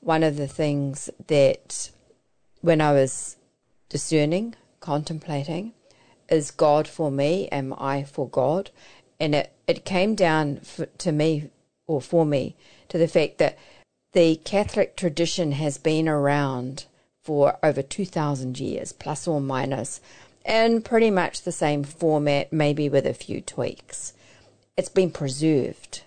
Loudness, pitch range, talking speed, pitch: -24 LUFS, 140-170 Hz, 140 wpm, 150 Hz